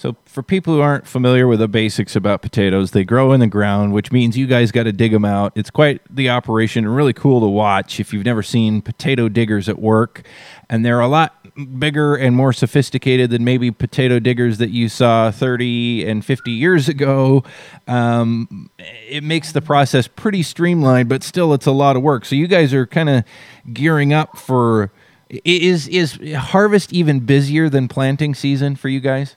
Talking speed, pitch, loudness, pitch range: 195 wpm, 130 Hz, -15 LUFS, 115-145 Hz